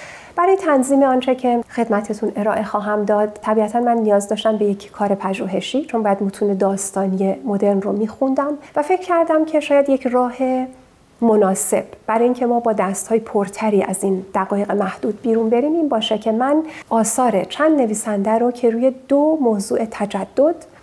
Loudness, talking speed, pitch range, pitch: -18 LUFS, 165 wpm, 205-260 Hz, 225 Hz